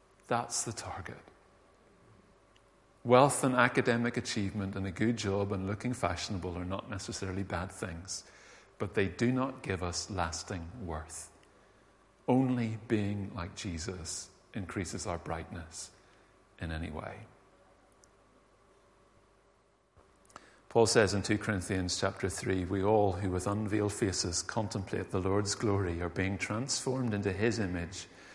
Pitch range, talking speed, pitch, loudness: 95-110 Hz, 125 wpm, 95 Hz, -33 LUFS